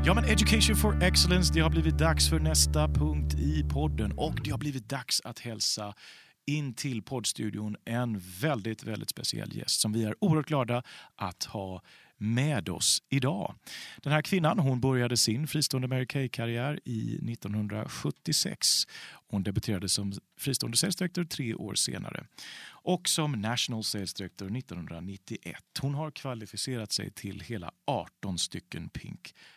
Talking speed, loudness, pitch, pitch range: 145 wpm, -29 LUFS, 110 Hz, 90-130 Hz